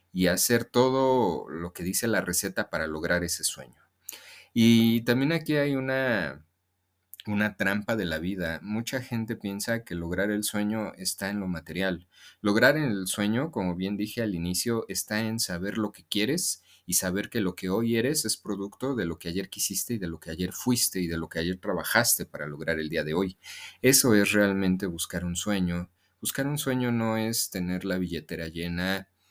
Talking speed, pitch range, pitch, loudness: 190 wpm, 90-115 Hz, 95 Hz, -27 LUFS